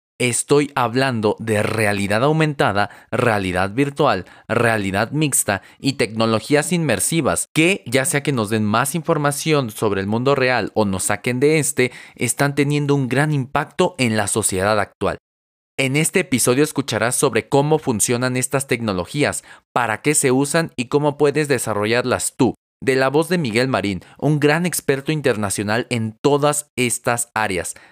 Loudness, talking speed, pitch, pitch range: -19 LUFS, 150 wpm, 125 Hz, 110-145 Hz